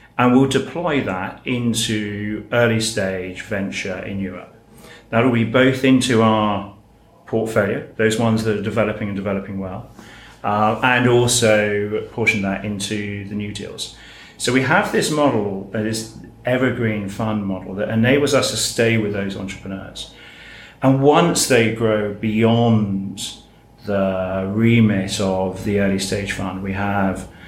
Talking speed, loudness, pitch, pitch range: 140 wpm, -19 LUFS, 110 Hz, 100-115 Hz